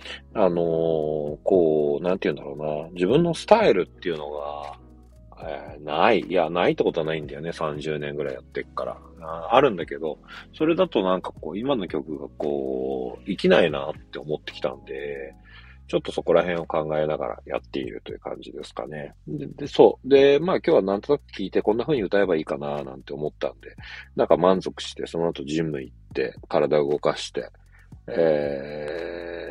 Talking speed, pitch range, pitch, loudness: 370 characters per minute, 70-85 Hz, 75 Hz, -24 LUFS